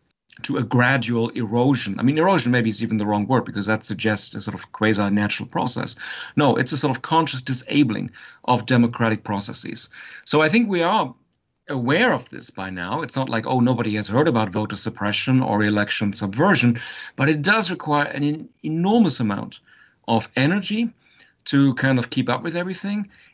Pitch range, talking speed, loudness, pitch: 110-150 Hz, 185 wpm, -21 LUFS, 125 Hz